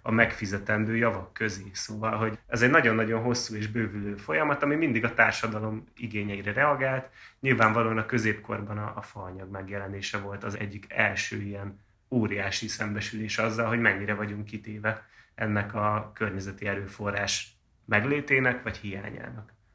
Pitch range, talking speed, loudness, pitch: 100-115 Hz, 135 wpm, -28 LUFS, 105 Hz